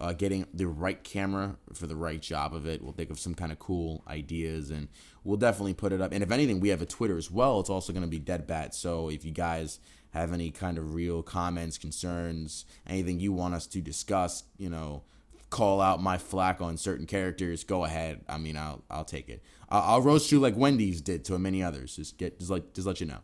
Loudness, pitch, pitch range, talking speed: -31 LUFS, 85 Hz, 80-95 Hz, 240 wpm